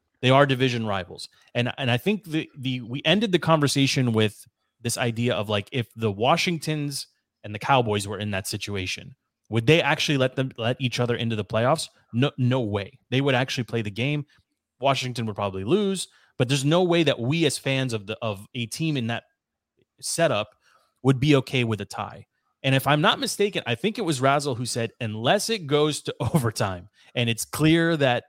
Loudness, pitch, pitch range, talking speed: -24 LUFS, 130 Hz, 115-150 Hz, 205 wpm